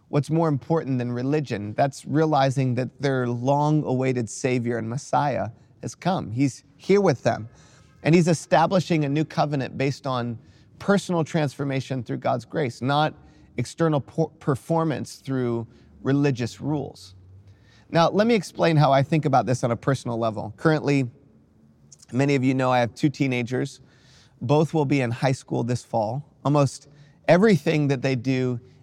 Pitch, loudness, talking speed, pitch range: 135 Hz, -24 LUFS, 155 wpm, 125-150 Hz